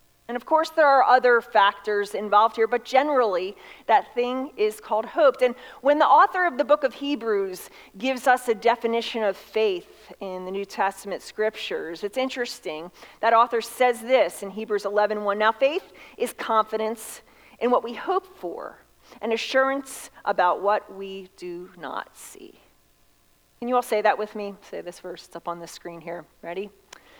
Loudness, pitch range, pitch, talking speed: -23 LUFS, 200-265 Hz, 230 Hz, 175 wpm